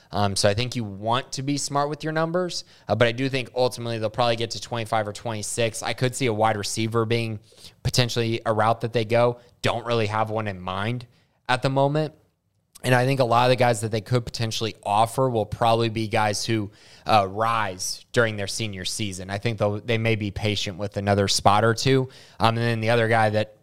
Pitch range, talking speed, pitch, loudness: 105-125 Hz, 230 wpm, 115 Hz, -24 LUFS